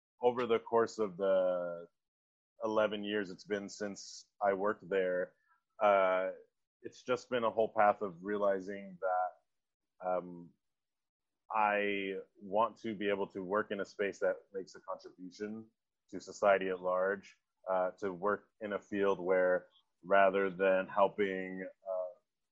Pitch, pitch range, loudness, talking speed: 100 Hz, 95-110 Hz, -34 LUFS, 140 wpm